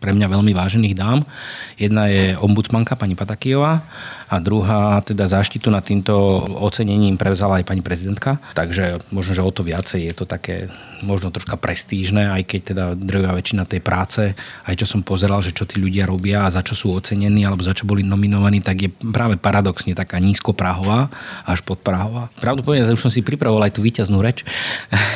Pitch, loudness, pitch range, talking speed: 100 Hz, -18 LUFS, 95-110 Hz, 185 wpm